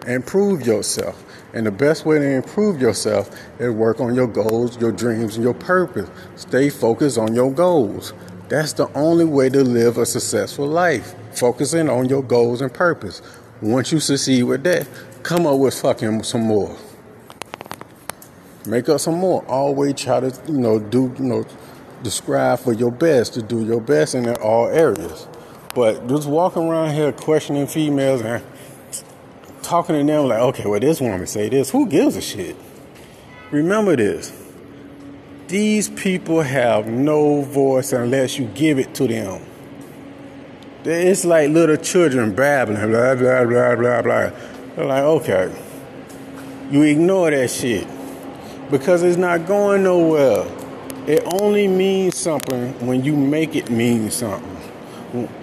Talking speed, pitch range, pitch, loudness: 150 wpm, 120-160 Hz, 135 Hz, -18 LUFS